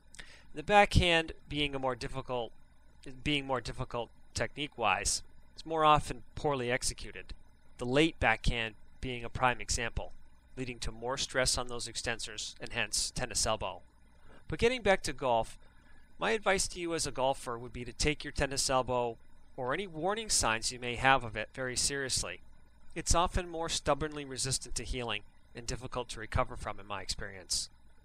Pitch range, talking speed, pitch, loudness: 115-145 Hz, 170 wpm, 125 Hz, -32 LUFS